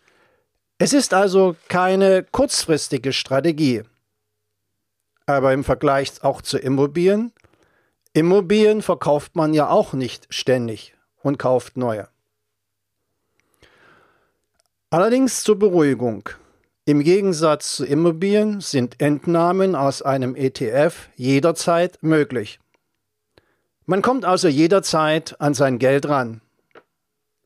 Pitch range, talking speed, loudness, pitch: 130-185 Hz, 95 wpm, -19 LUFS, 145 Hz